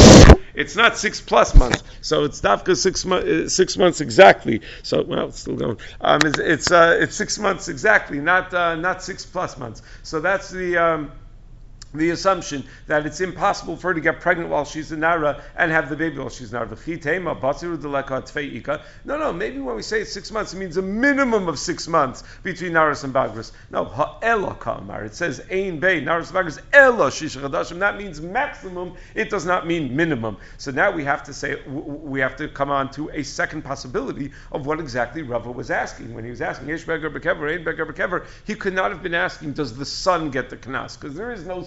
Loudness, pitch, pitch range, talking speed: -20 LUFS, 160 Hz, 140-185 Hz, 185 wpm